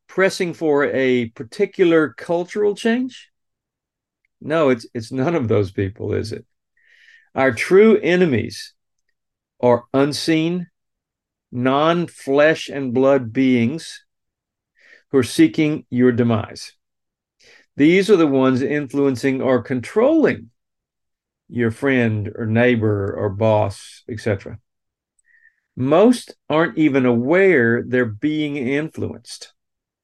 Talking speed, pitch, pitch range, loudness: 100 wpm, 135 Hz, 120-170 Hz, -18 LUFS